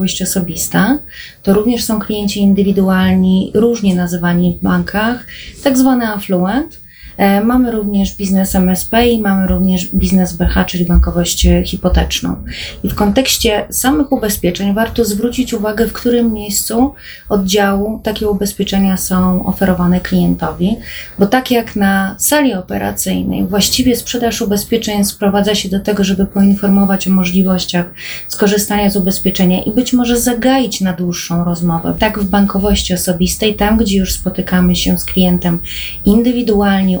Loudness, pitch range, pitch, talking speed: -13 LUFS, 185-220 Hz, 200 Hz, 130 wpm